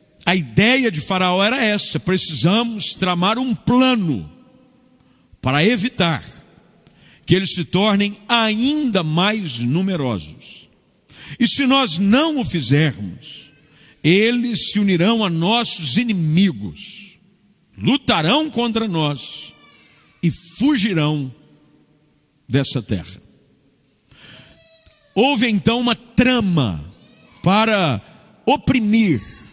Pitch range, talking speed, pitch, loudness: 155-225 Hz, 90 wpm, 185 Hz, -17 LUFS